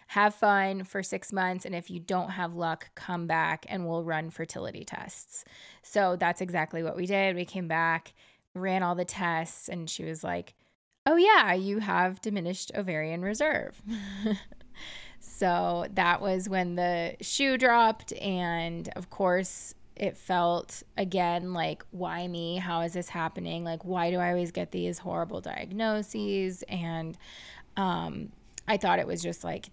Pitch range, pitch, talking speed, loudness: 165-195 Hz, 180 Hz, 160 wpm, -30 LUFS